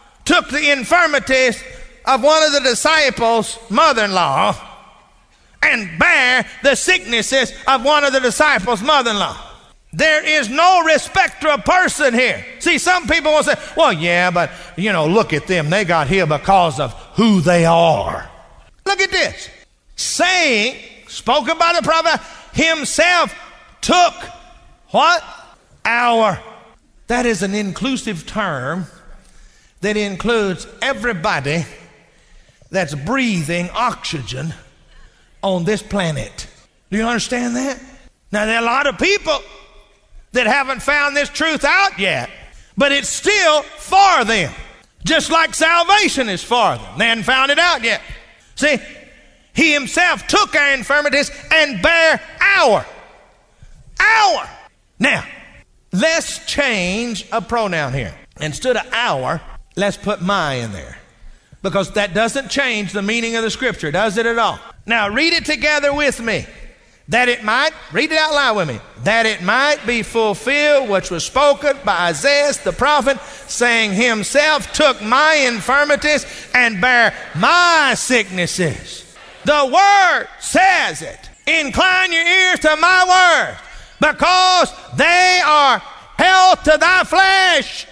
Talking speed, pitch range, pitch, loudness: 135 wpm, 210-310 Hz, 265 Hz, -15 LUFS